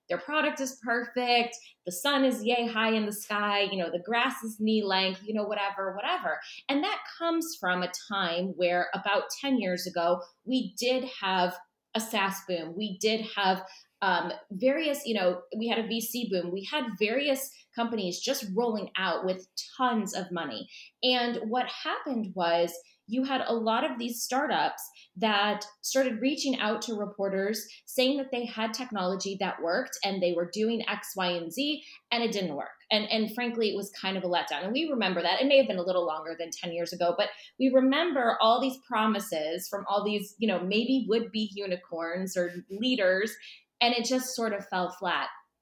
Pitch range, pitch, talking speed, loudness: 190-250 Hz, 215 Hz, 195 wpm, -29 LUFS